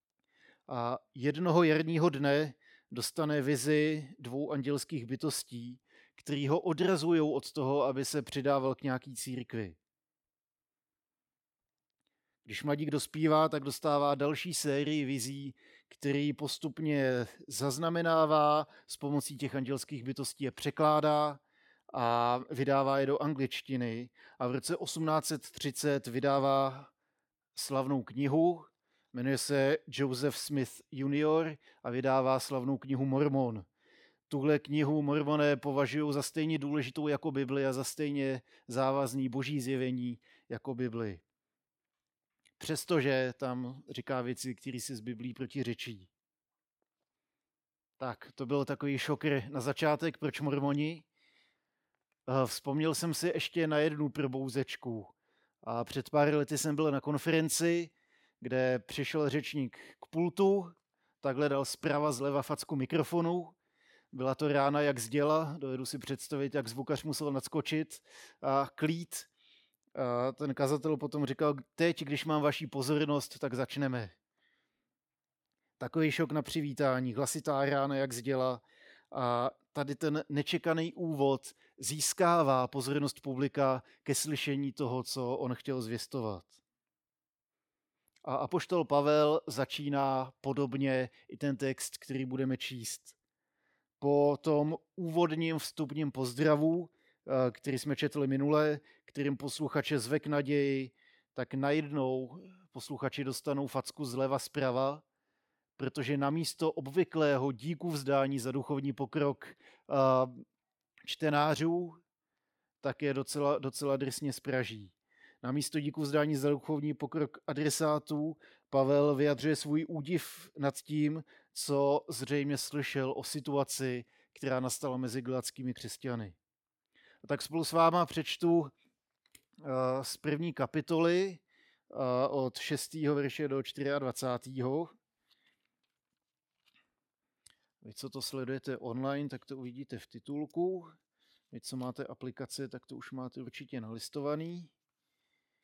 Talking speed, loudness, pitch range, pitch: 110 wpm, -33 LUFS, 130-150 Hz, 140 Hz